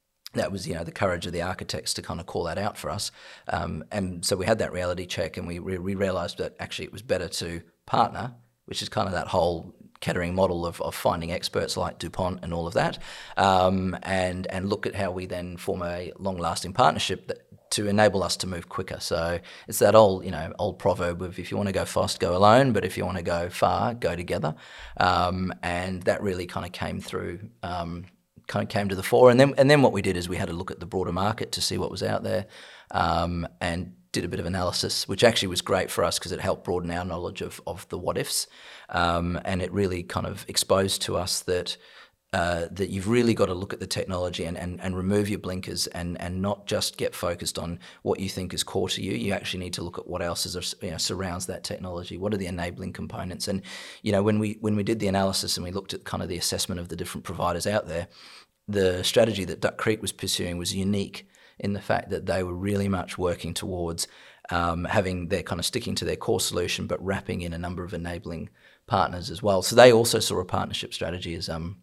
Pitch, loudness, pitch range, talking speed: 90 Hz, -26 LUFS, 85-100 Hz, 245 wpm